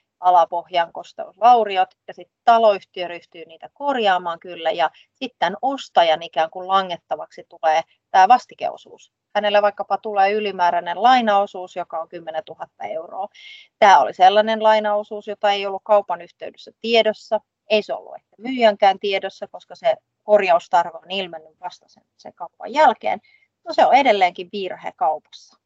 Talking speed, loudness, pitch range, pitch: 140 wpm, -19 LUFS, 175-220 Hz, 195 Hz